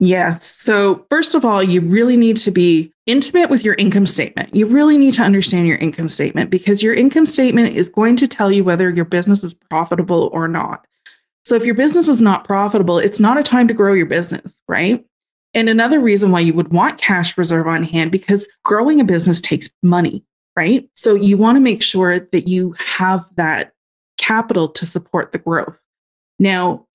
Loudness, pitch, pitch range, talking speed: -14 LUFS, 195 Hz, 175-230 Hz, 200 wpm